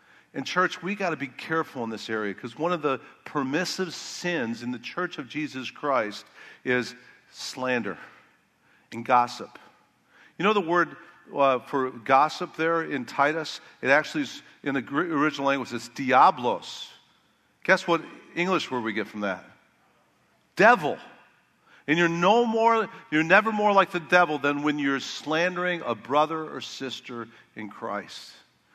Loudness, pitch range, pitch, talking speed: -25 LUFS, 125-180 Hz, 150 Hz, 155 wpm